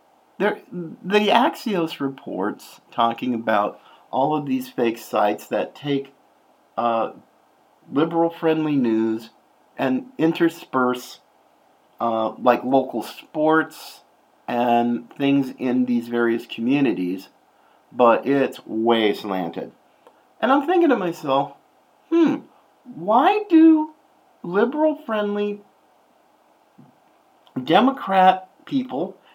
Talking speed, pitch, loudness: 90 wpm, 155 Hz, -21 LUFS